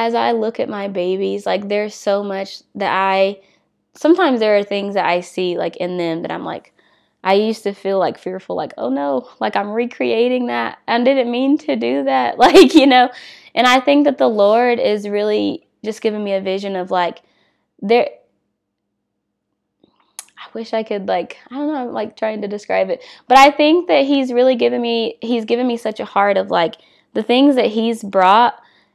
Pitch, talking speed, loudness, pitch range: 220 Hz, 205 wpm, -16 LUFS, 195-255 Hz